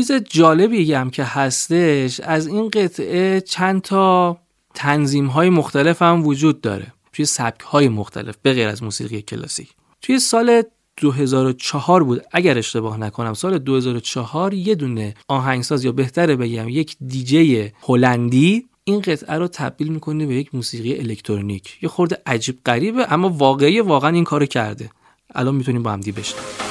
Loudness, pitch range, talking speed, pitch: -18 LUFS, 120-170 Hz, 150 wpm, 140 Hz